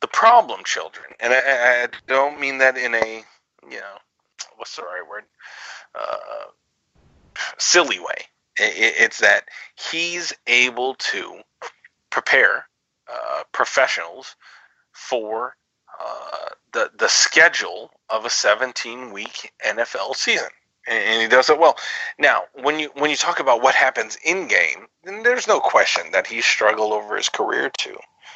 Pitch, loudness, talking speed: 145 Hz, -18 LUFS, 140 wpm